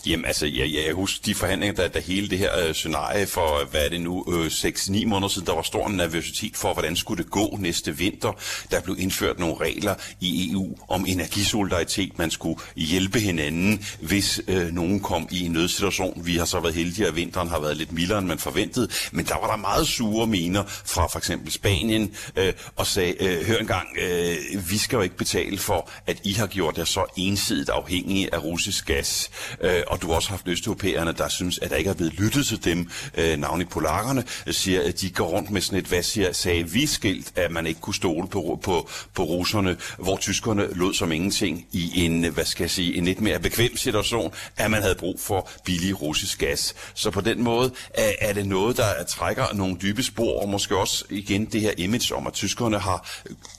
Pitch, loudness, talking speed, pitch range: 95 Hz, -24 LUFS, 210 wpm, 85-105 Hz